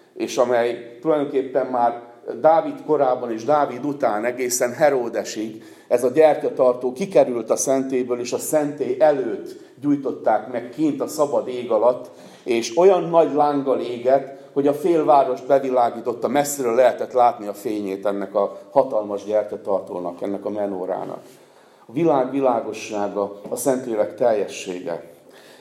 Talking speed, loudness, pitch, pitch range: 130 wpm, -21 LUFS, 130 Hz, 115-150 Hz